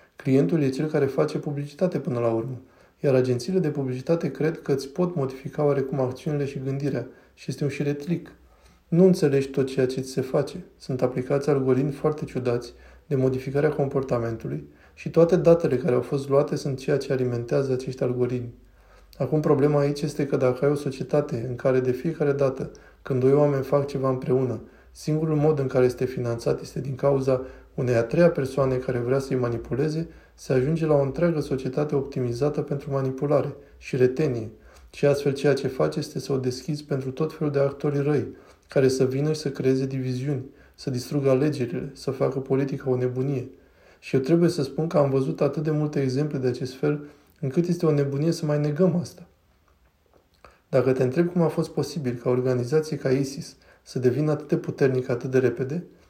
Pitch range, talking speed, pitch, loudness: 130-150 Hz, 185 wpm, 140 Hz, -25 LUFS